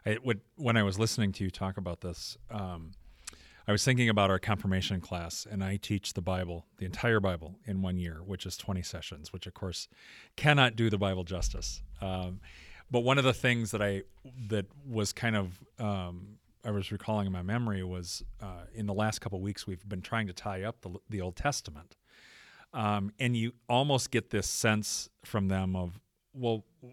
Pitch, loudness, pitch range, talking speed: 100 Hz, -32 LUFS, 90-115 Hz, 200 wpm